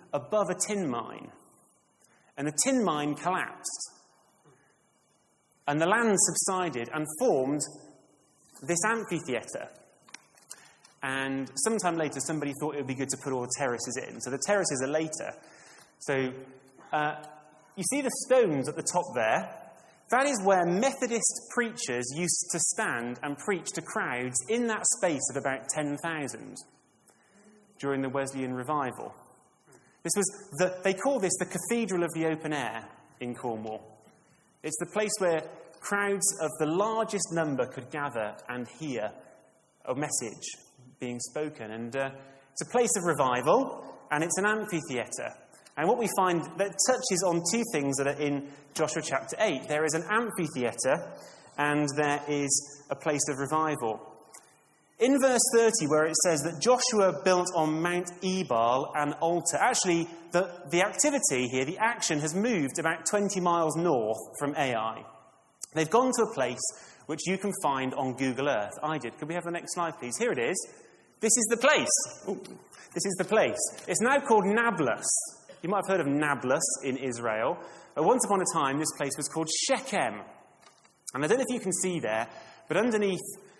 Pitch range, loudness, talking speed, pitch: 140-195 Hz, -28 LUFS, 165 wpm, 160 Hz